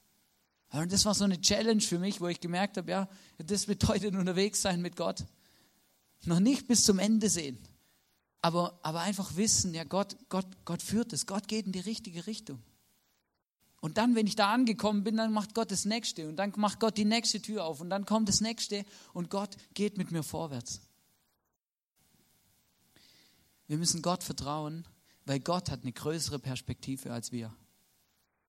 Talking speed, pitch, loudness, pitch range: 175 wpm, 190 Hz, -31 LUFS, 160-210 Hz